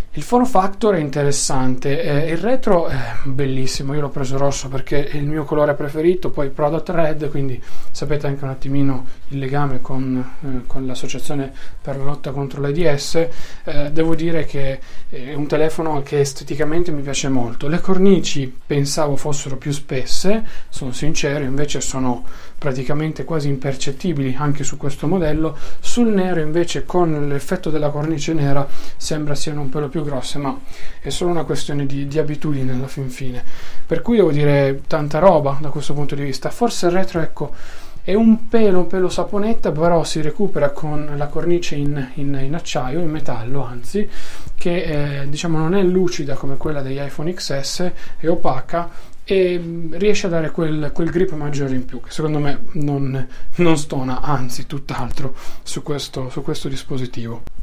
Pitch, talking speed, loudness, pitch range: 145 Hz, 170 wpm, -21 LUFS, 140-165 Hz